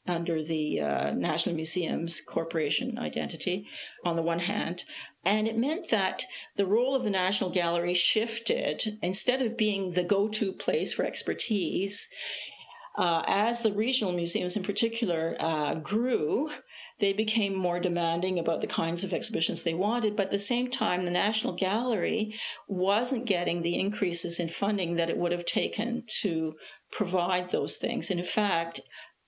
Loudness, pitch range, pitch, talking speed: -28 LUFS, 175-215 Hz, 195 Hz, 160 wpm